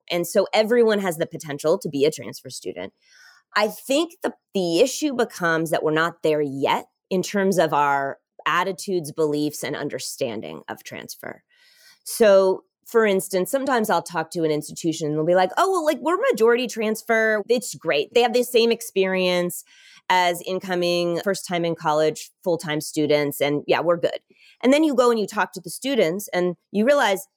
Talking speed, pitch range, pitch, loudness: 185 wpm, 165-235 Hz, 190 Hz, -22 LUFS